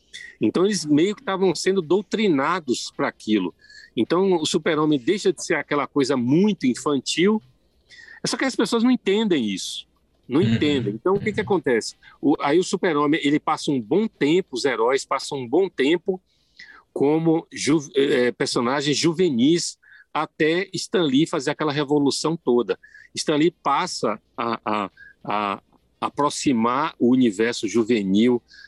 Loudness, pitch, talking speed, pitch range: -22 LUFS, 165 Hz, 150 wpm, 140-215 Hz